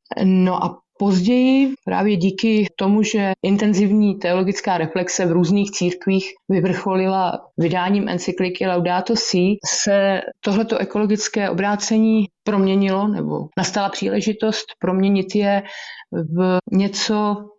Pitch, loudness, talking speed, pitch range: 195 Hz, -19 LUFS, 100 wpm, 185-210 Hz